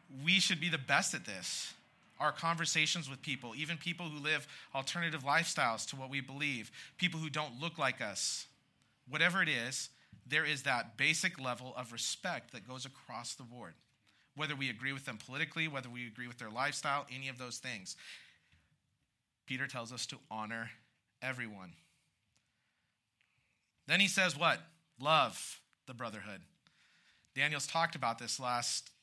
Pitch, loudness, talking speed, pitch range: 135 Hz, -36 LUFS, 155 wpm, 120-155 Hz